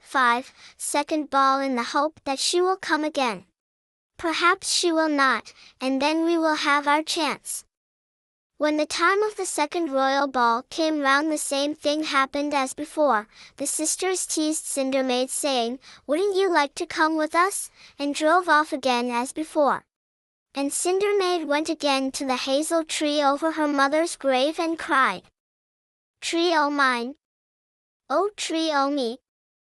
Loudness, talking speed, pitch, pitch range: -23 LUFS, 160 wpm, 295 Hz, 270-320 Hz